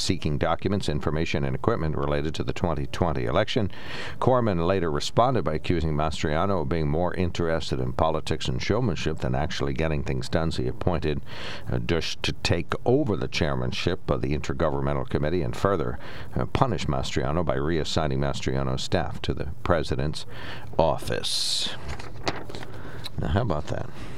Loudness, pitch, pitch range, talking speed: -27 LUFS, 80 Hz, 70-90 Hz, 145 wpm